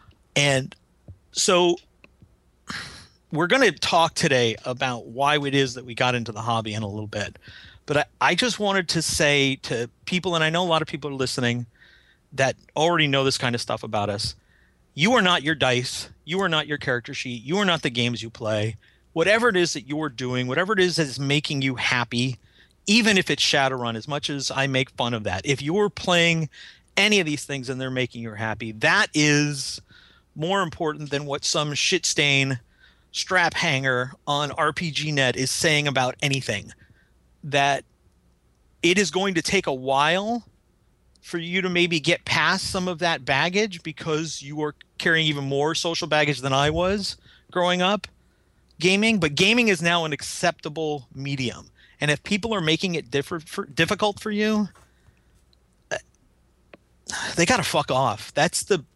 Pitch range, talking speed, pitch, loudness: 125-170 Hz, 180 wpm, 145 Hz, -23 LUFS